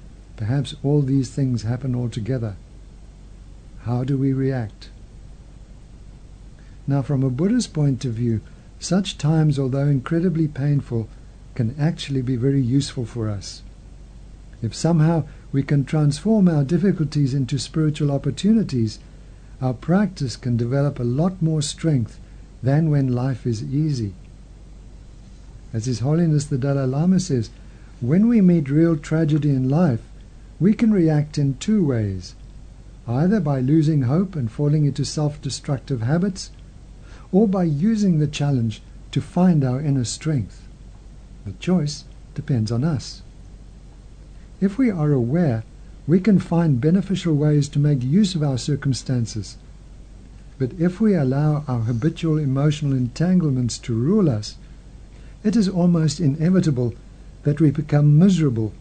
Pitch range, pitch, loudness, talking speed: 120-160 Hz, 140 Hz, -21 LUFS, 135 wpm